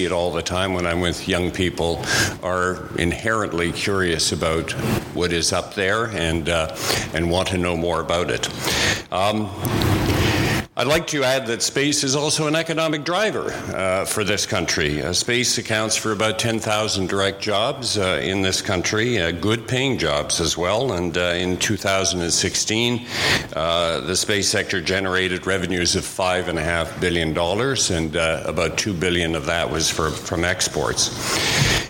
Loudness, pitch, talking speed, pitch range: -20 LUFS, 95 Hz, 160 wpm, 85-110 Hz